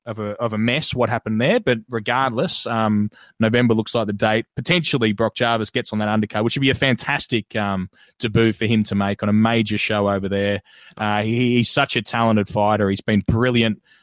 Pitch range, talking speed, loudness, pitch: 105-120 Hz, 215 wpm, -20 LUFS, 110 Hz